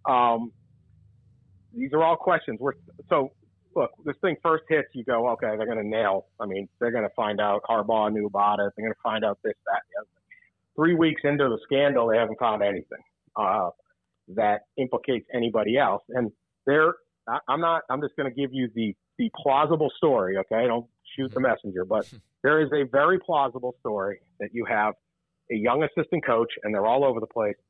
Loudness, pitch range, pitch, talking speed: -25 LUFS, 105-145 Hz, 120 Hz, 195 wpm